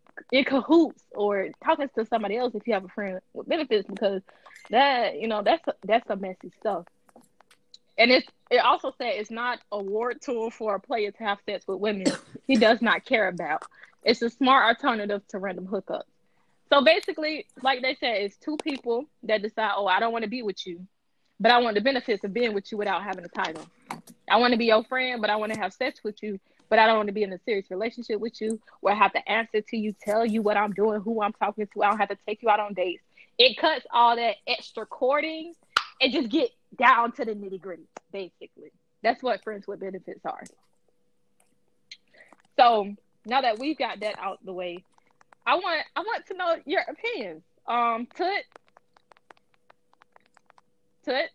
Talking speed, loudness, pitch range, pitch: 205 wpm, -25 LUFS, 205-260 Hz, 225 Hz